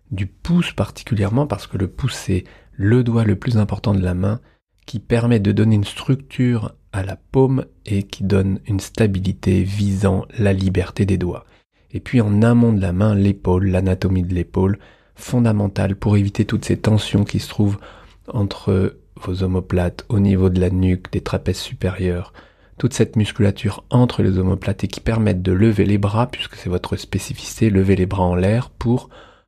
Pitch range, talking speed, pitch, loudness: 95-110 Hz, 180 wpm, 100 Hz, -19 LUFS